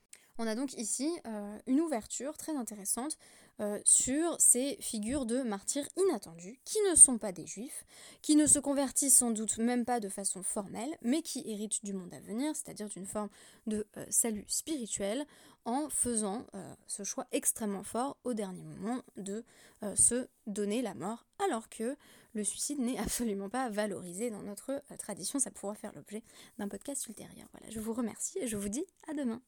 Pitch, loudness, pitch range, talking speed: 230 Hz, -31 LUFS, 210-270 Hz, 185 wpm